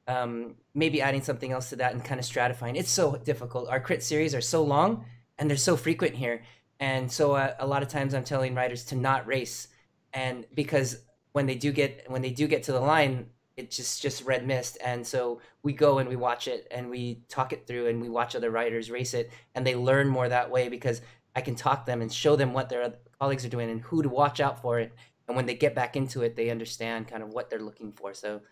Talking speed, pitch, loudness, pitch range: 250 wpm, 125 Hz, -29 LUFS, 120-140 Hz